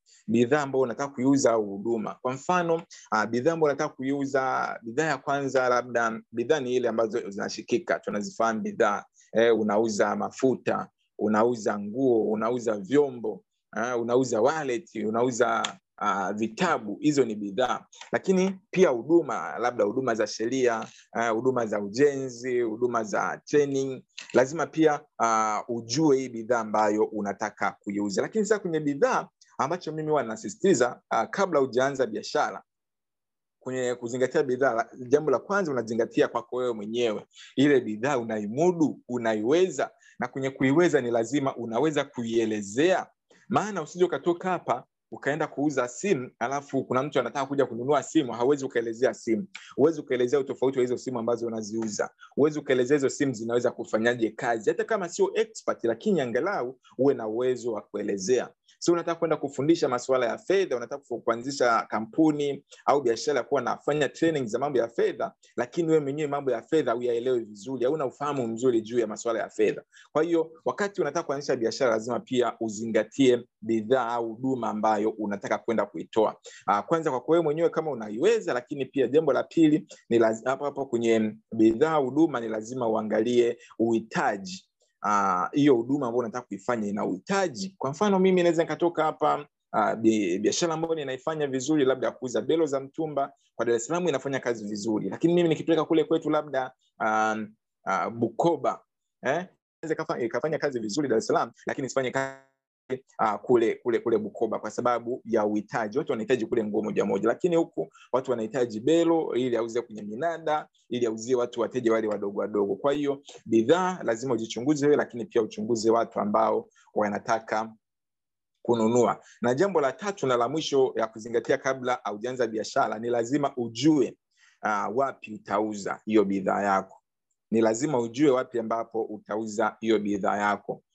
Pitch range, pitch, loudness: 115-155 Hz, 125 Hz, -27 LUFS